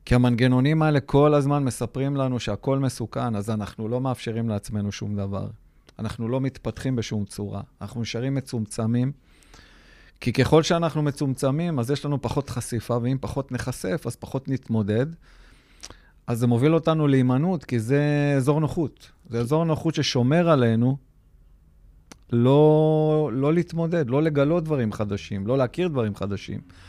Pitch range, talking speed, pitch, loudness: 110-145 Hz, 145 wpm, 125 Hz, -24 LUFS